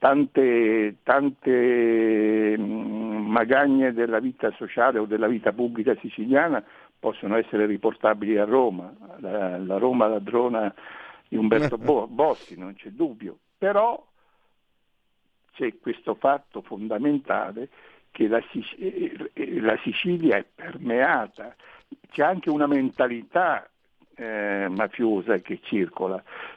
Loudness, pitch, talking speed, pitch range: -24 LUFS, 120 Hz, 105 wpm, 110-150 Hz